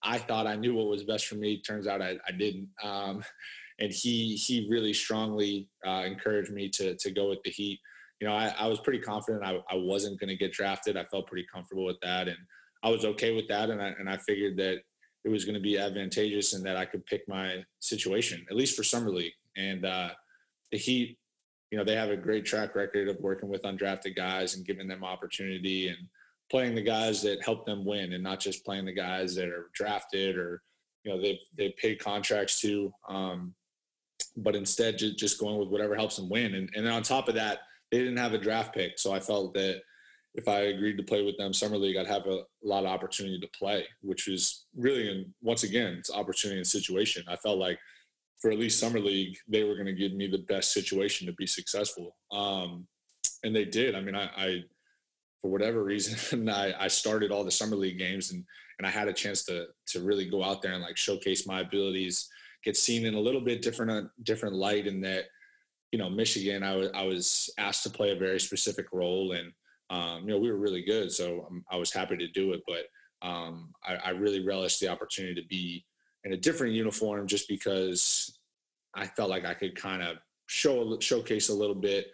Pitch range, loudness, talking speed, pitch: 95-105 Hz, -30 LUFS, 220 wpm, 100 Hz